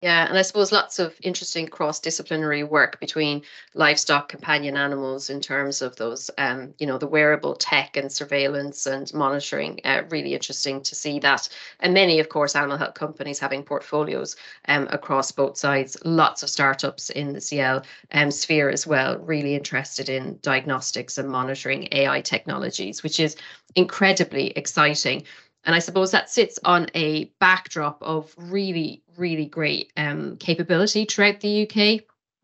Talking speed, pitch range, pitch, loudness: 160 wpm, 140-170 Hz, 150 Hz, -22 LUFS